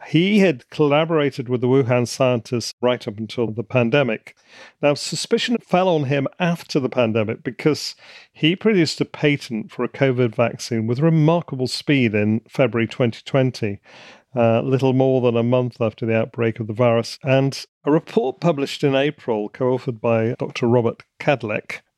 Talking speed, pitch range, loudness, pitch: 160 wpm, 120-150 Hz, -20 LUFS, 130 Hz